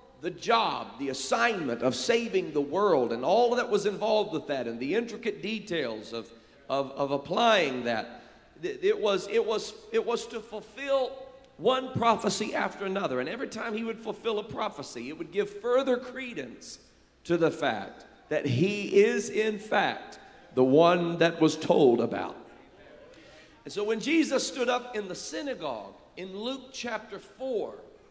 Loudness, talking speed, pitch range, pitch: -28 LUFS, 160 wpm, 170-240 Hz, 210 Hz